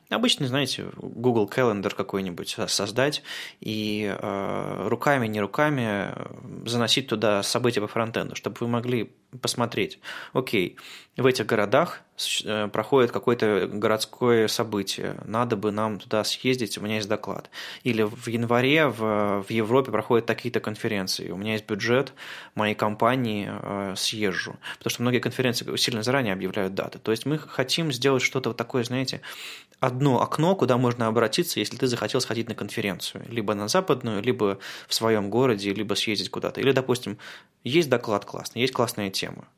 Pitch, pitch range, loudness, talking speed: 115 Hz, 105-125 Hz, -25 LUFS, 150 wpm